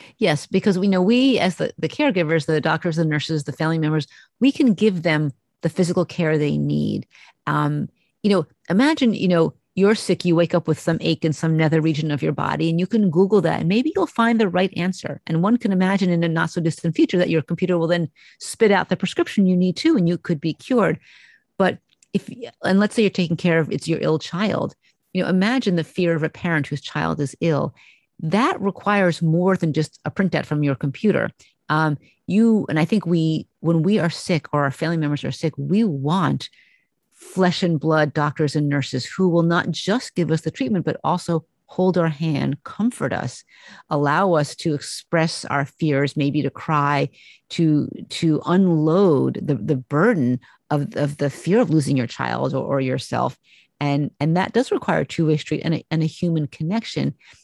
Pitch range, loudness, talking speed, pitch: 155-190 Hz, -21 LUFS, 210 wpm, 165 Hz